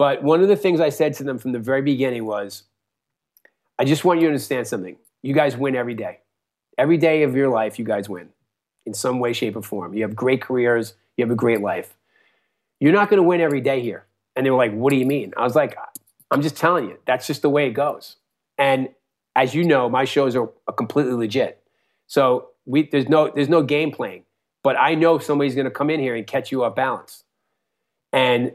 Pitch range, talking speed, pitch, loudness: 120-145 Hz, 230 wpm, 135 Hz, -20 LUFS